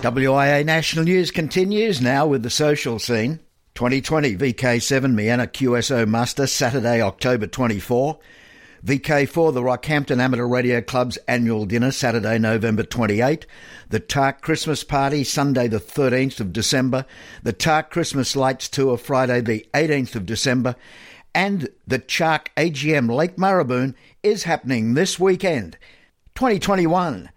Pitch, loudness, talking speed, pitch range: 130 Hz, -20 LUFS, 125 wpm, 120-155 Hz